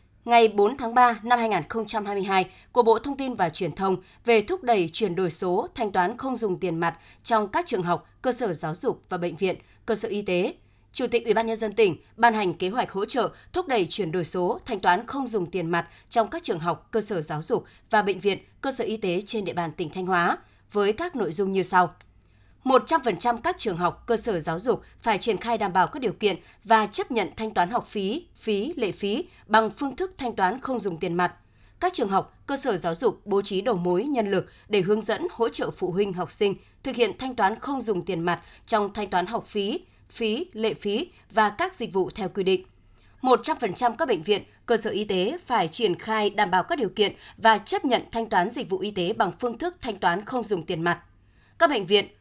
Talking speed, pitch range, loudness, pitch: 240 wpm, 185-235 Hz, -25 LUFS, 210 Hz